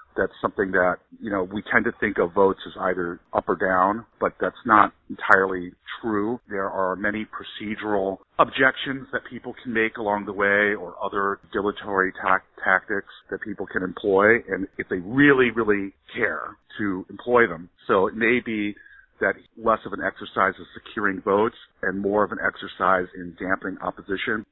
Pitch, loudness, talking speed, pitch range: 105 Hz, -23 LUFS, 175 wpm, 95-115 Hz